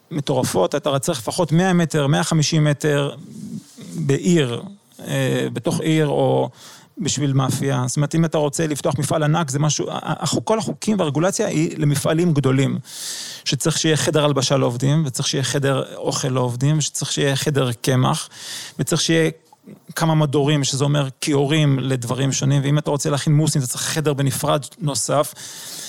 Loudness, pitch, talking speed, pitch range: -20 LUFS, 150 Hz, 150 wpm, 140-160 Hz